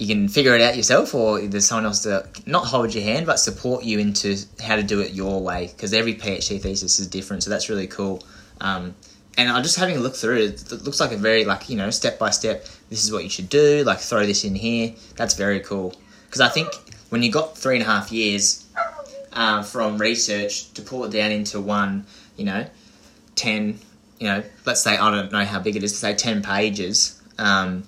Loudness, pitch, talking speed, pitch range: -21 LUFS, 105 Hz, 235 wpm, 100-115 Hz